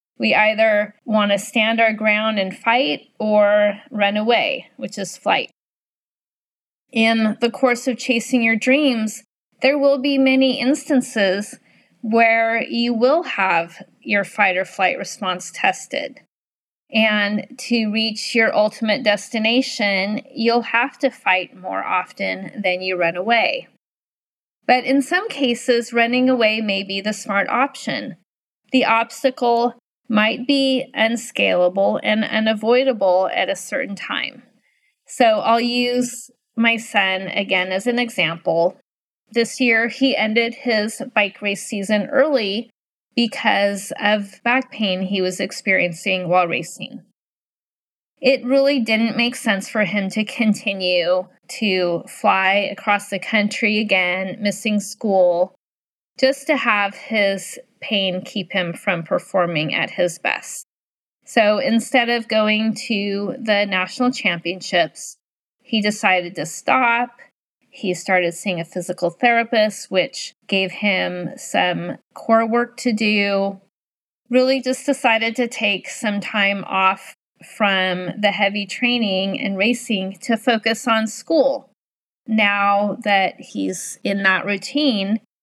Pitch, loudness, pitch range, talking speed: 215 Hz, -19 LUFS, 195-245 Hz, 125 wpm